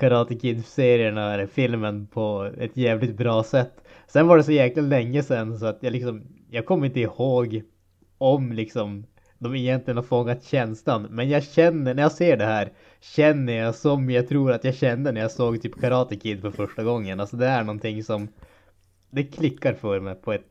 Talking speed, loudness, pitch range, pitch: 200 wpm, -23 LUFS, 110-130 Hz, 120 Hz